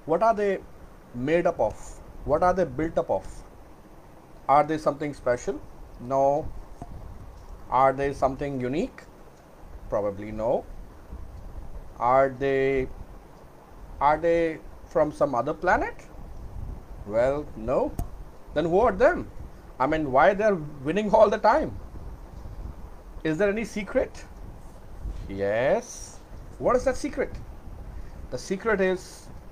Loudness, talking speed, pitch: -25 LUFS, 115 wpm, 135 Hz